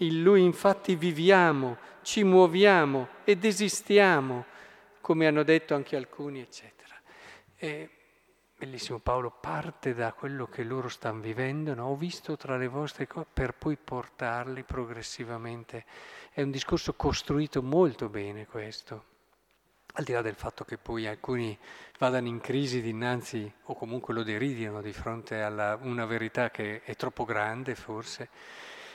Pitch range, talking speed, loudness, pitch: 115-155 Hz, 140 wpm, -29 LUFS, 130 Hz